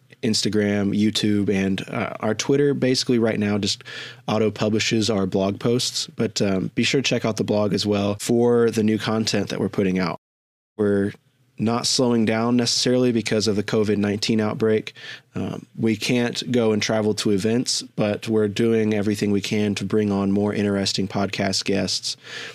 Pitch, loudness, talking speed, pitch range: 110 Hz, -21 LUFS, 175 wpm, 100-120 Hz